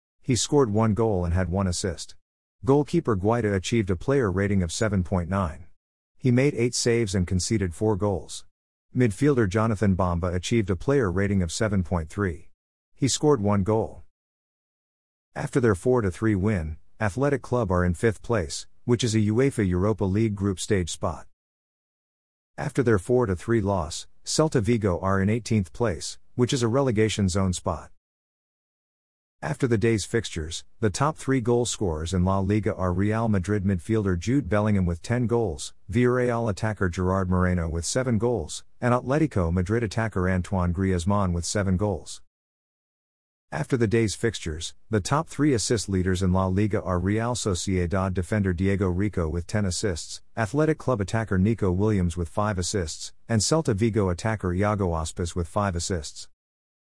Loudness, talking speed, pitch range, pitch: -25 LUFS, 155 wpm, 90-115 Hz, 100 Hz